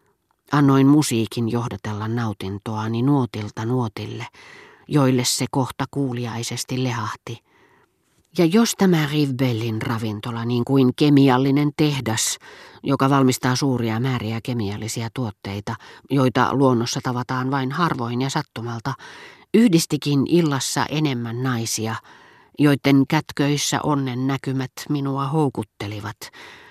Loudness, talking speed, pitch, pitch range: -21 LUFS, 95 wpm, 130 Hz, 115-140 Hz